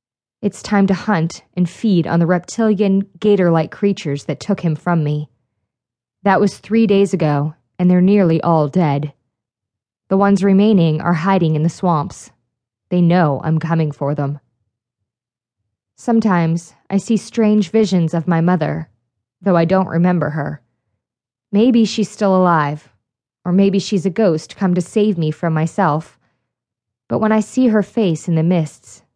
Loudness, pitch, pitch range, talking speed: -16 LUFS, 170 Hz, 145-195 Hz, 160 wpm